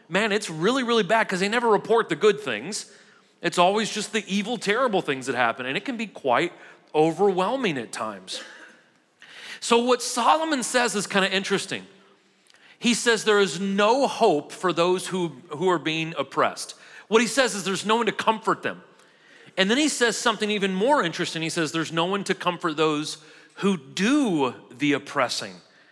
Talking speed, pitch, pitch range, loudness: 185 wpm, 195 Hz, 170-225 Hz, -23 LUFS